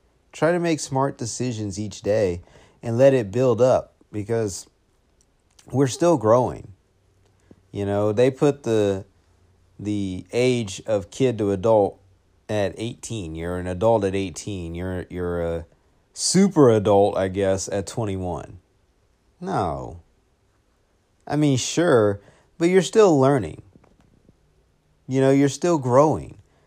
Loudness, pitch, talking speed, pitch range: -21 LUFS, 105 Hz, 125 wpm, 95-130 Hz